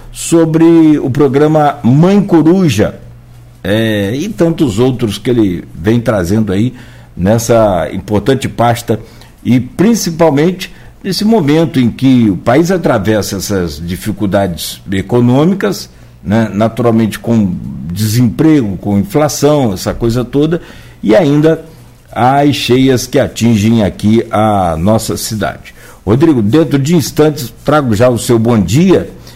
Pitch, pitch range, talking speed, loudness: 120 Hz, 105-150 Hz, 120 wpm, -11 LUFS